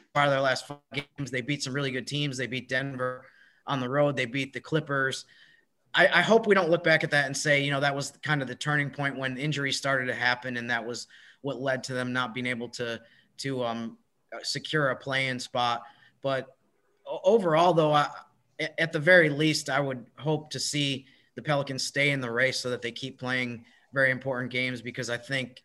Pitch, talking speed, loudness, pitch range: 135 Hz, 220 wpm, -27 LUFS, 125-145 Hz